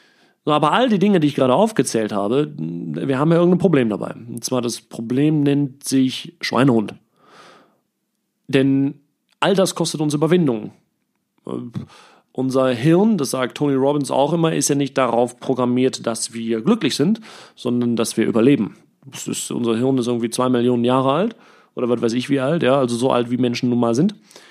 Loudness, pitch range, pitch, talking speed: -19 LUFS, 120-150 Hz, 130 Hz, 180 wpm